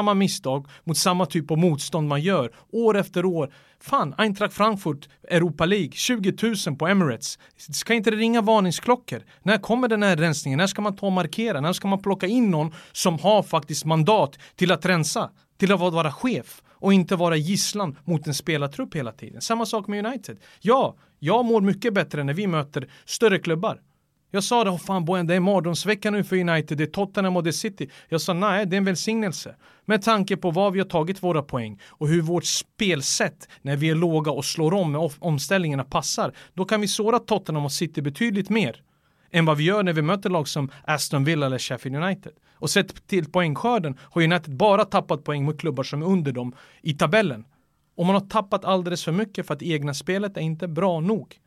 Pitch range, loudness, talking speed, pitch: 155-200 Hz, -23 LUFS, 210 wpm, 180 Hz